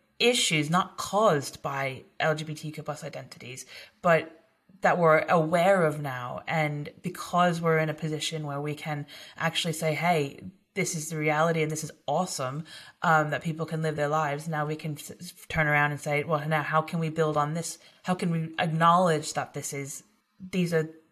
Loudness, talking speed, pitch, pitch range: -27 LUFS, 180 wpm, 155 Hz, 150-170 Hz